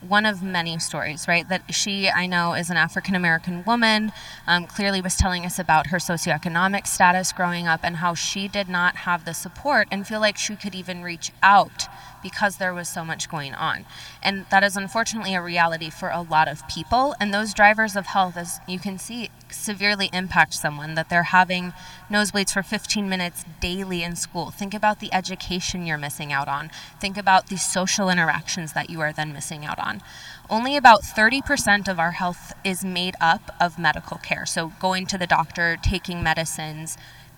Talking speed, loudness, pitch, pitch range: 195 wpm, -22 LUFS, 180 Hz, 165-200 Hz